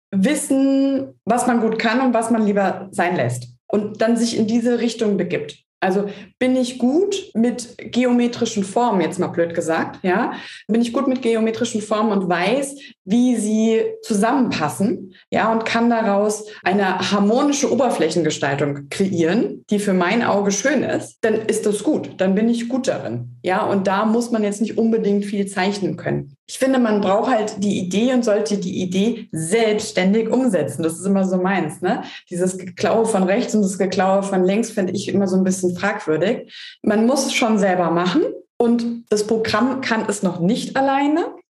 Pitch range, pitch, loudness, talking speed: 190-235 Hz, 215 Hz, -19 LUFS, 180 wpm